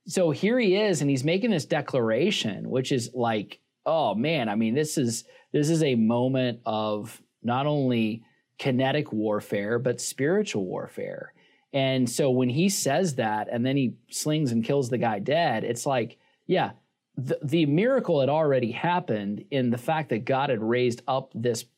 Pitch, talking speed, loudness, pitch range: 135 Hz, 175 wpm, -26 LUFS, 120-160 Hz